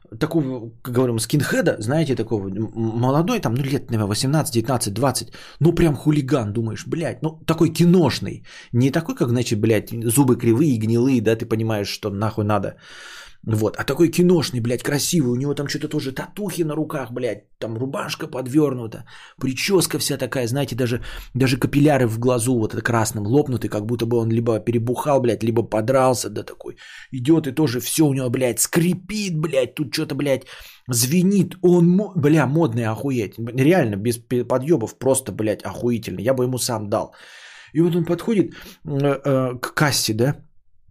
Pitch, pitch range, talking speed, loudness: 130 Hz, 115-155 Hz, 165 wpm, -20 LUFS